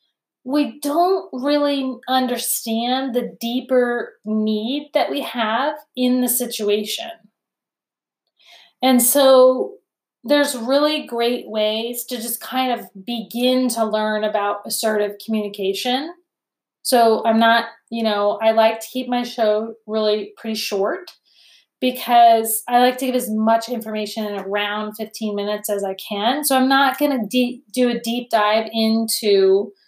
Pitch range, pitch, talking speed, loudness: 215-255 Hz, 235 Hz, 135 wpm, -19 LUFS